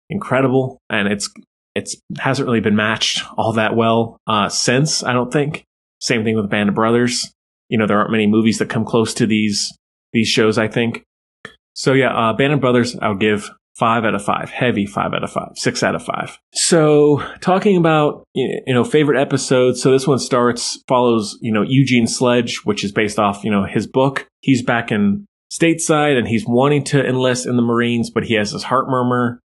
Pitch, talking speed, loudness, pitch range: 120 Hz, 205 wpm, -17 LUFS, 110-135 Hz